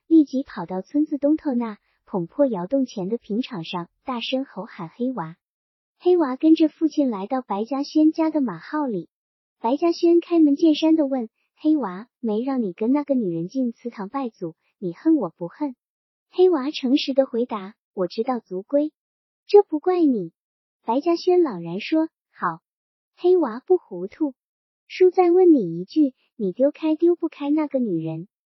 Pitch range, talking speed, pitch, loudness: 200-310 Hz, 235 characters per minute, 270 Hz, -22 LUFS